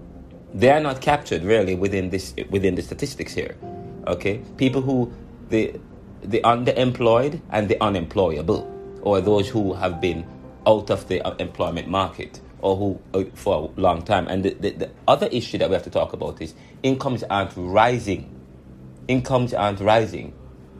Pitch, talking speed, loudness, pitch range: 95 Hz, 160 wpm, -22 LUFS, 85-115 Hz